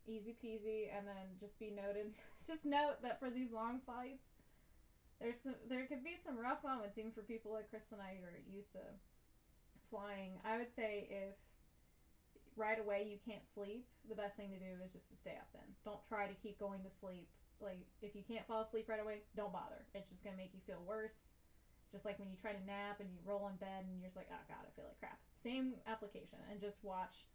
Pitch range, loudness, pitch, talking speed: 200-225 Hz, -47 LUFS, 210 Hz, 230 wpm